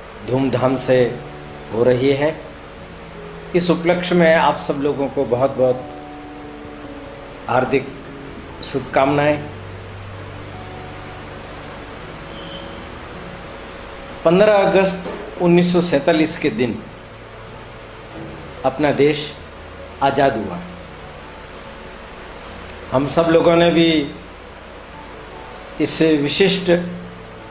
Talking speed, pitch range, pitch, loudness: 70 wpm, 90-155 Hz, 130 Hz, -17 LUFS